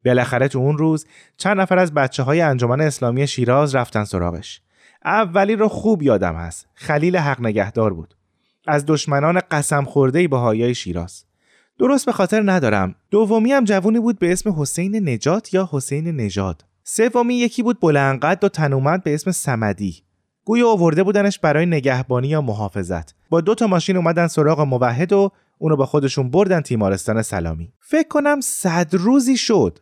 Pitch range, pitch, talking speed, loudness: 120-195 Hz, 150 Hz, 160 wpm, -18 LUFS